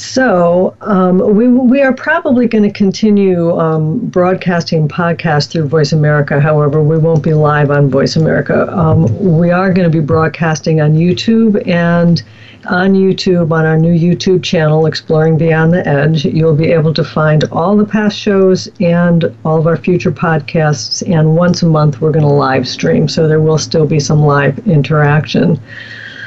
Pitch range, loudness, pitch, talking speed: 155-185 Hz, -11 LUFS, 165 Hz, 175 wpm